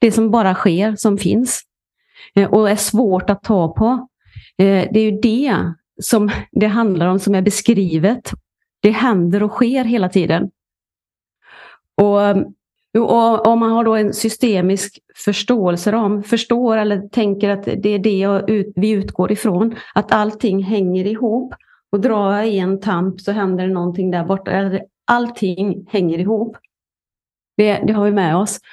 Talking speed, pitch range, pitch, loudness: 155 wpm, 195-225 Hz, 205 Hz, -16 LUFS